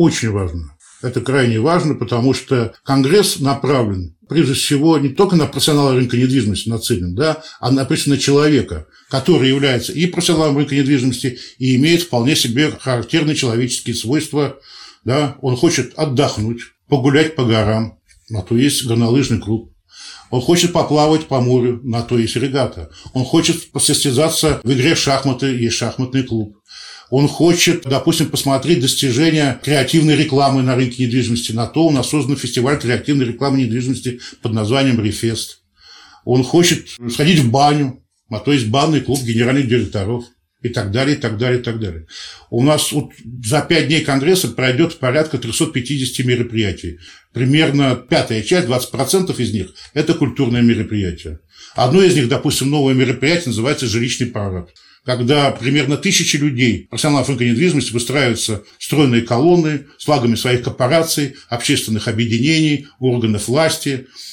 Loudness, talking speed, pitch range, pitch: -16 LUFS, 145 wpm, 120-150 Hz, 130 Hz